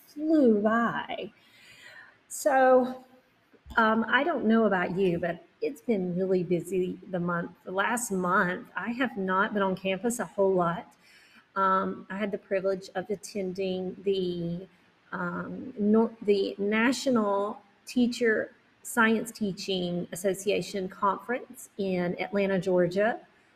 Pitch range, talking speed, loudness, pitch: 185-225 Hz, 120 wpm, -28 LUFS, 200 Hz